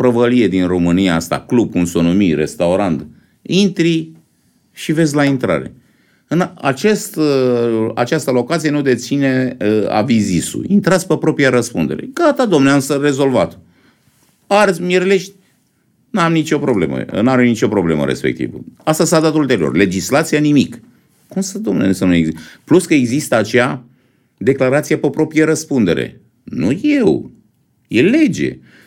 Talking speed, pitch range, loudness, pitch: 135 wpm, 120-165 Hz, -15 LUFS, 140 Hz